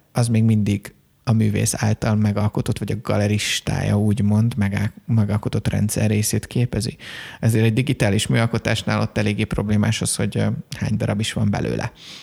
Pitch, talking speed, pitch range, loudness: 110 Hz, 140 wpm, 105-115 Hz, -21 LUFS